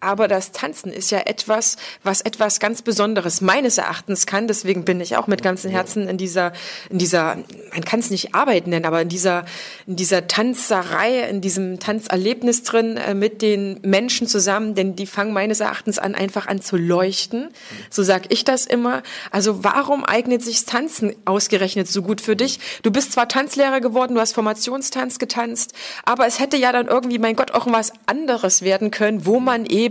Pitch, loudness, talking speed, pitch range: 210 Hz, -19 LUFS, 190 wpm, 190-235 Hz